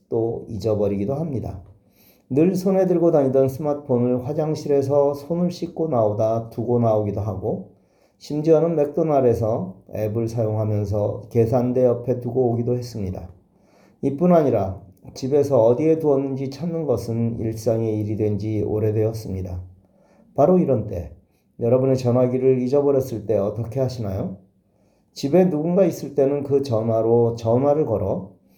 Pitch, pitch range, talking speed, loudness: 120 Hz, 110-145 Hz, 315 characters per minute, -21 LUFS